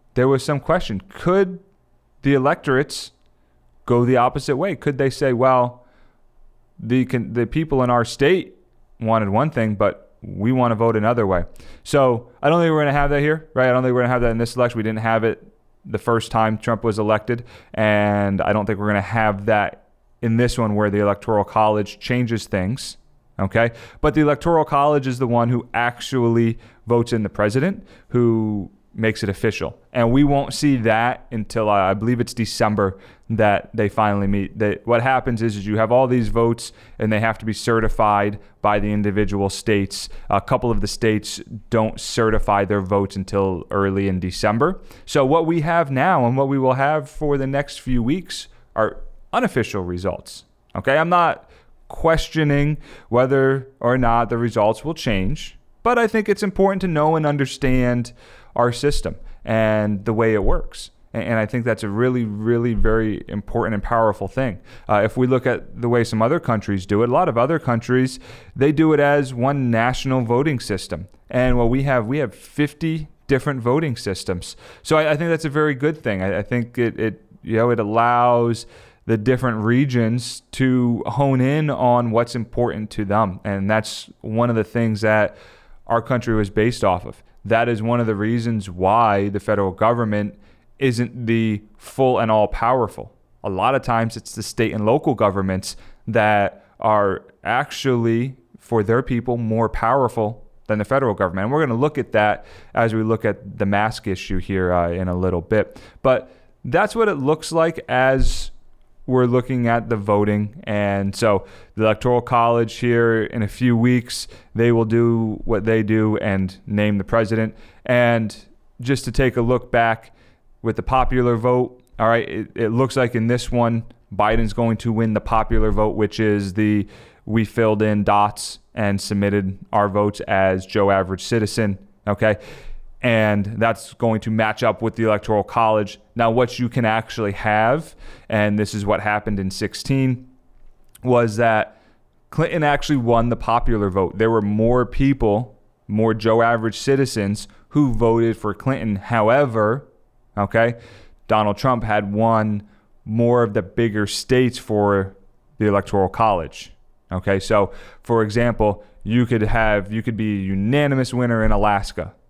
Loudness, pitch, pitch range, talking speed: -20 LUFS, 115 Hz, 105-125 Hz, 180 wpm